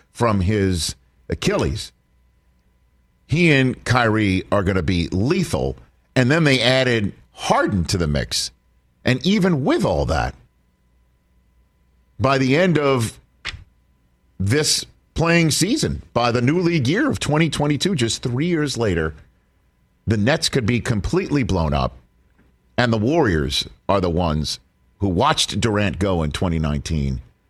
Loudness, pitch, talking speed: -20 LUFS, 95 Hz, 135 wpm